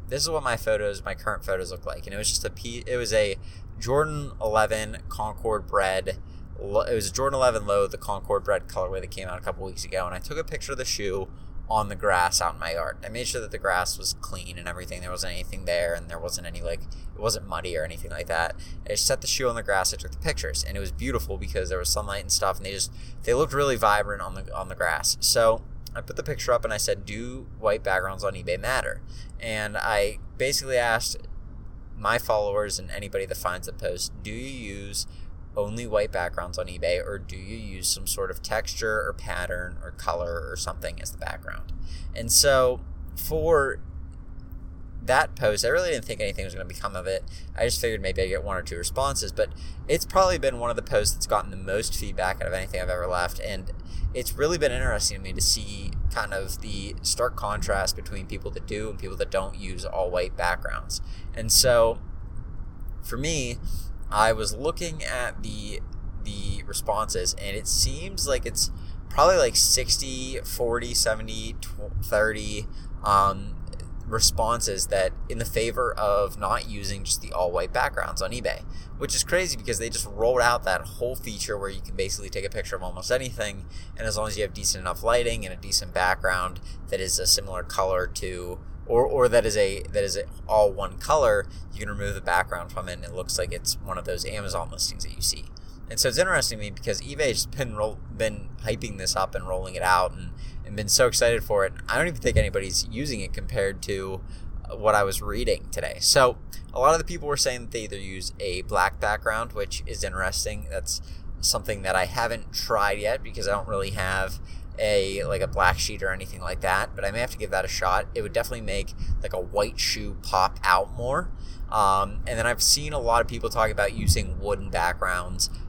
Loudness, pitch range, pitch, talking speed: -26 LUFS, 90-115 Hz, 100 Hz, 220 wpm